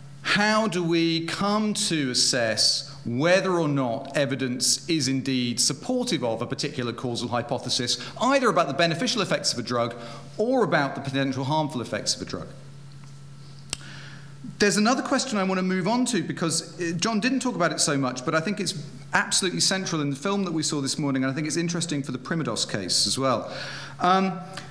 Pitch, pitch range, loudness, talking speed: 155 Hz, 135-185 Hz, -24 LUFS, 190 wpm